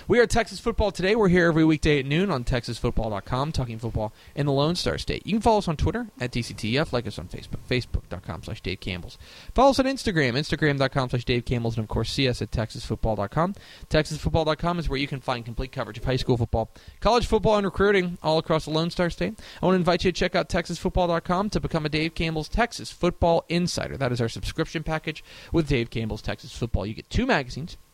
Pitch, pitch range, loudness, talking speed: 150 Hz, 120-175 Hz, -25 LUFS, 225 wpm